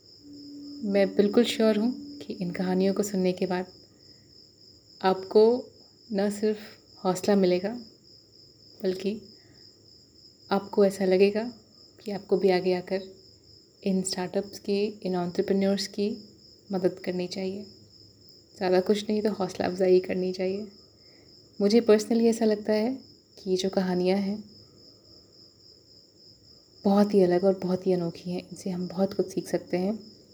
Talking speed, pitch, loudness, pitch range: 135 wpm, 195 Hz, -27 LUFS, 180-210 Hz